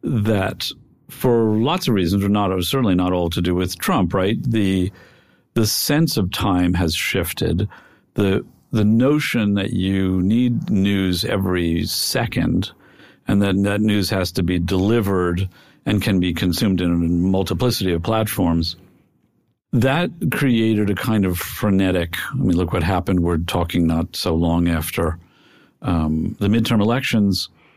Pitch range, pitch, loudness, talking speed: 90-110 Hz, 95 Hz, -19 LUFS, 150 wpm